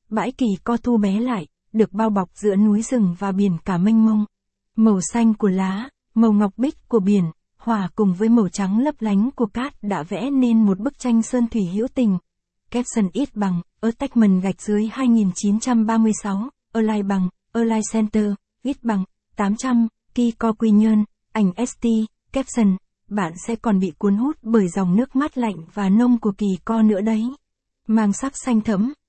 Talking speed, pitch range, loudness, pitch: 190 wpm, 200-235 Hz, -20 LUFS, 220 Hz